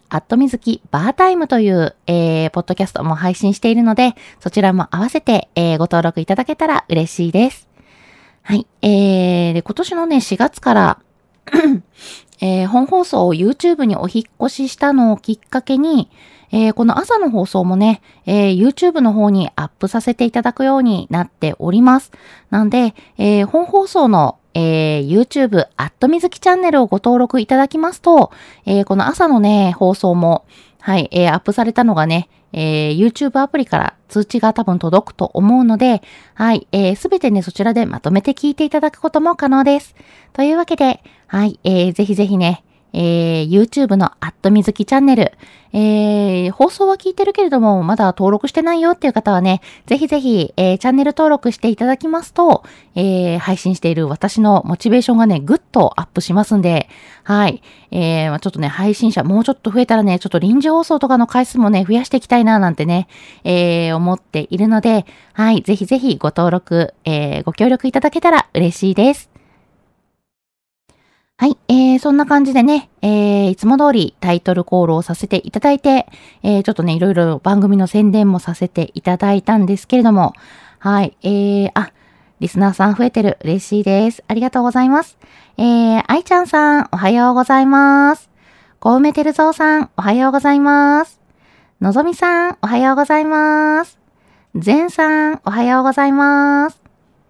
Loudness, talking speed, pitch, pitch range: -14 LUFS, 380 characters per minute, 220 Hz, 185-270 Hz